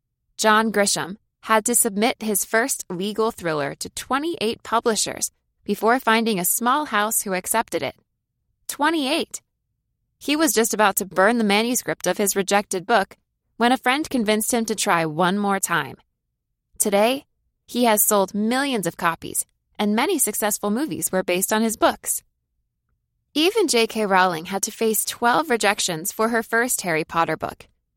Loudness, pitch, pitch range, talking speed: -21 LUFS, 215 Hz, 190-235 Hz, 155 wpm